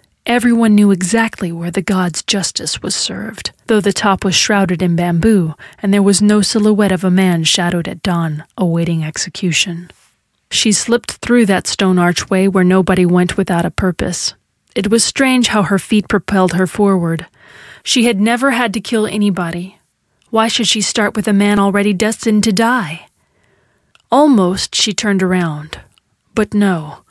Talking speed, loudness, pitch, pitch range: 165 wpm, -14 LUFS, 195 Hz, 180-215 Hz